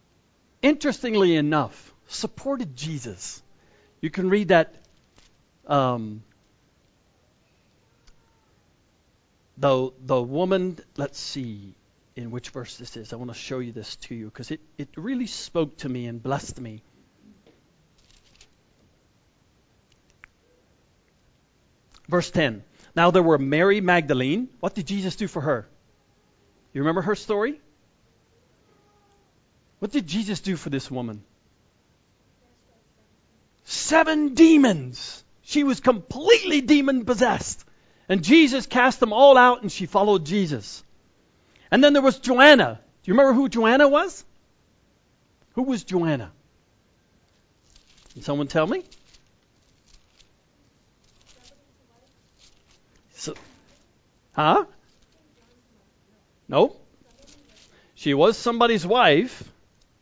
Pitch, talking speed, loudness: 175 Hz, 100 wpm, -21 LUFS